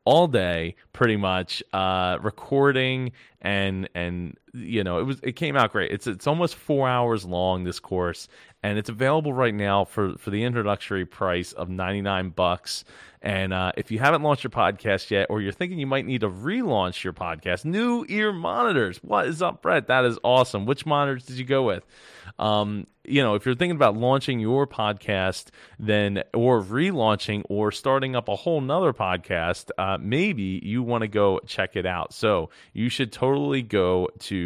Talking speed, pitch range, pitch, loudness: 185 wpm, 95-130 Hz, 110 Hz, -24 LUFS